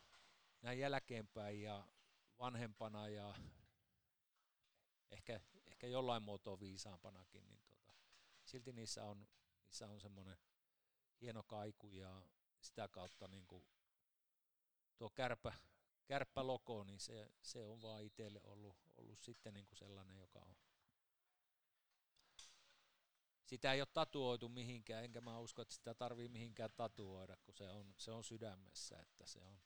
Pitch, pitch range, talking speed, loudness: 105 Hz, 100-120 Hz, 125 wpm, -51 LUFS